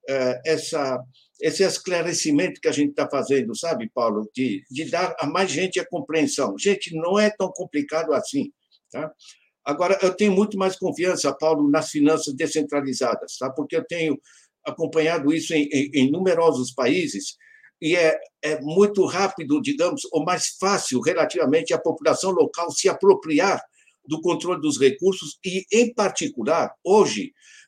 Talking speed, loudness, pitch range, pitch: 150 wpm, -22 LUFS, 150-195 Hz, 170 Hz